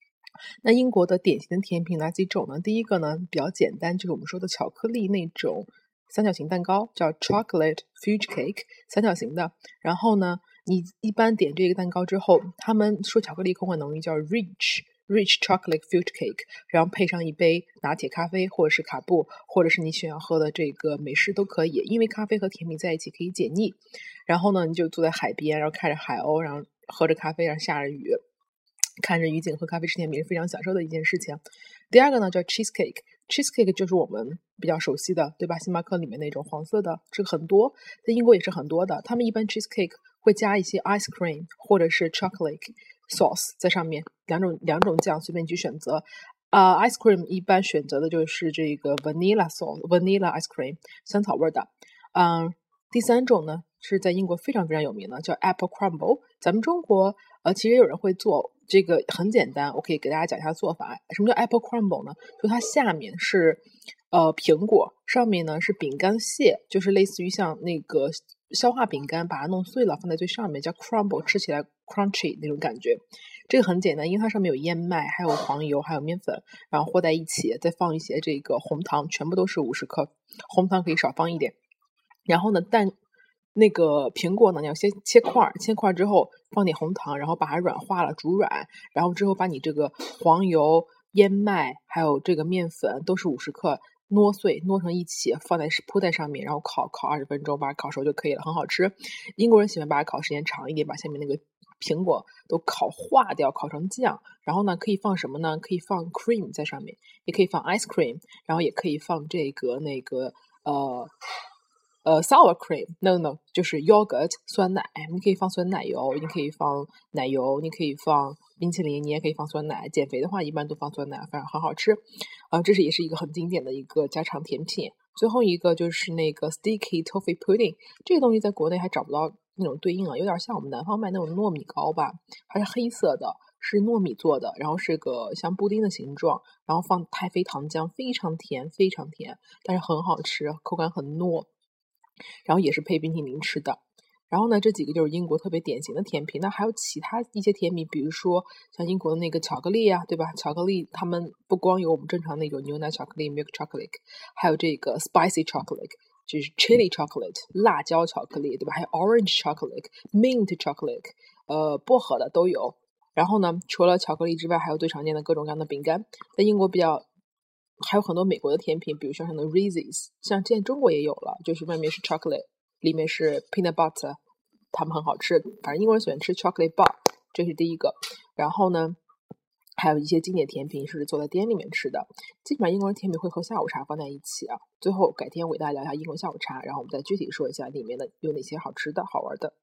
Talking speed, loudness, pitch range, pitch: 395 characters per minute, -25 LUFS, 160-210 Hz, 180 Hz